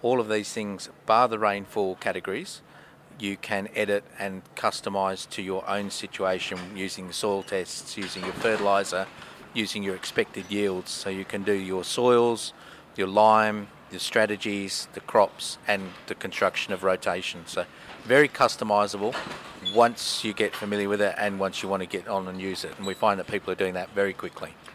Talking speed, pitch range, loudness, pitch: 180 wpm, 95-105 Hz, -27 LUFS, 100 Hz